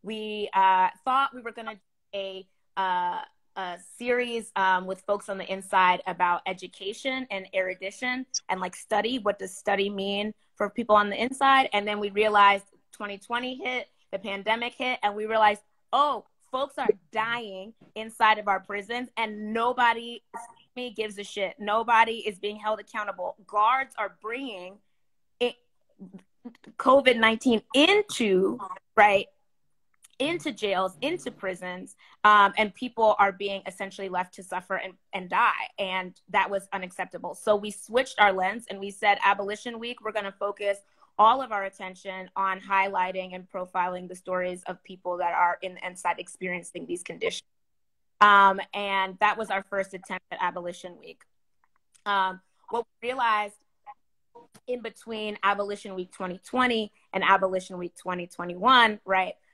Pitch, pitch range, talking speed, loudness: 205 Hz, 190-230 Hz, 150 wpm, -26 LUFS